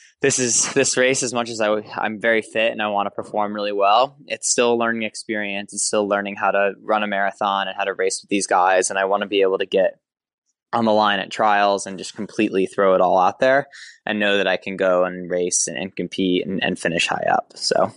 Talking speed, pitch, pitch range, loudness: 255 wpm, 100 Hz, 95-110 Hz, -20 LUFS